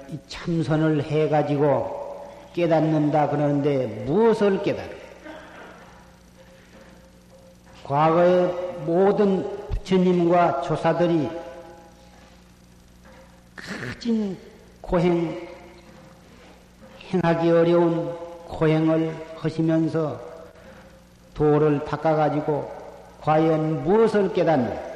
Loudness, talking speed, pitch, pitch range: -22 LUFS, 160 characters per minute, 165 Hz, 150-175 Hz